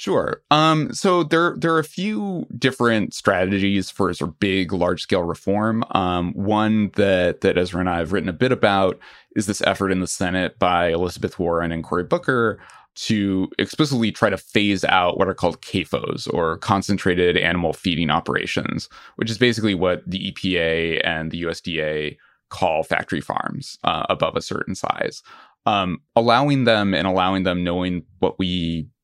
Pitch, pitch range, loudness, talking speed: 95 Hz, 90-110 Hz, -21 LUFS, 165 wpm